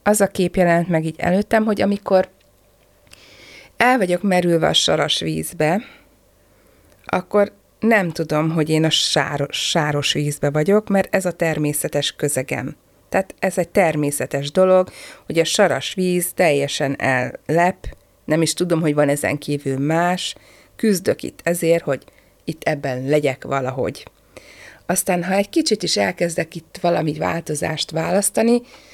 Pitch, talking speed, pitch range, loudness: 170 Hz, 140 wpm, 150-190 Hz, -19 LUFS